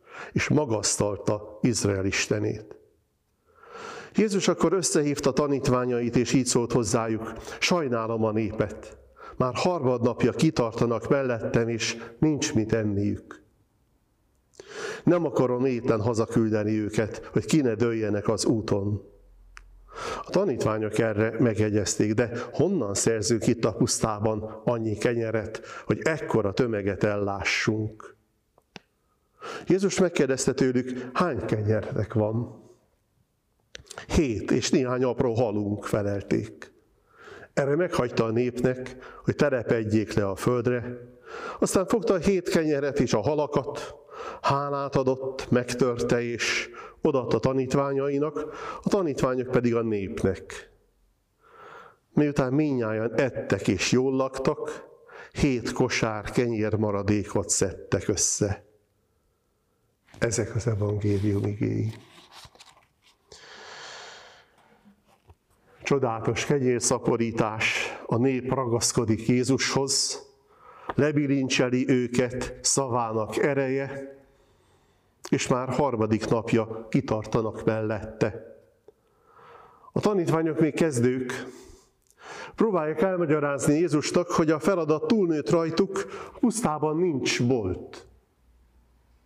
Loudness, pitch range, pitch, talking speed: -26 LUFS, 110-150 Hz, 125 Hz, 90 wpm